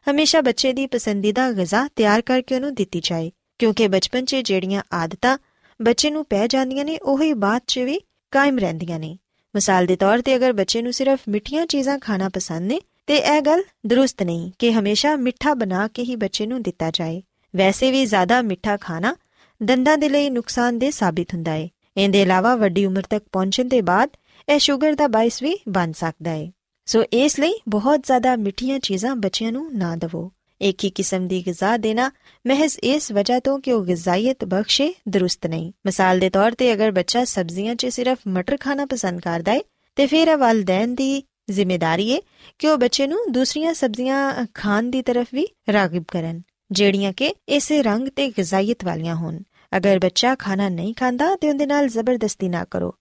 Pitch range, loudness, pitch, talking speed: 190-270 Hz, -20 LUFS, 230 Hz, 180 wpm